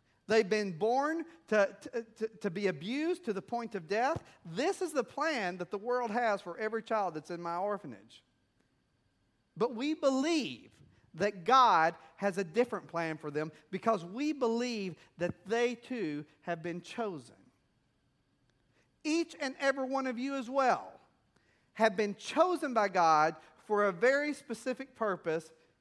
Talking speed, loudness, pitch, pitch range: 155 wpm, -33 LUFS, 215 Hz, 175-260 Hz